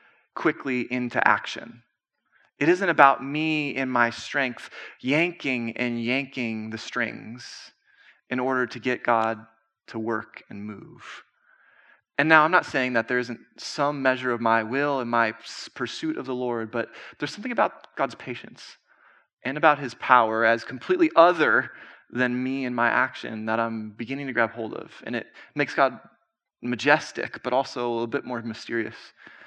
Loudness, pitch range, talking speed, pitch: -24 LUFS, 115-140 Hz, 160 wpm, 125 Hz